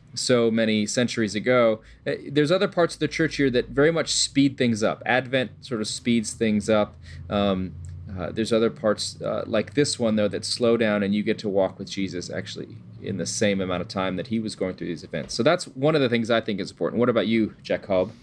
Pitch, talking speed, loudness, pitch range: 110 Hz, 235 wpm, -24 LUFS, 100-125 Hz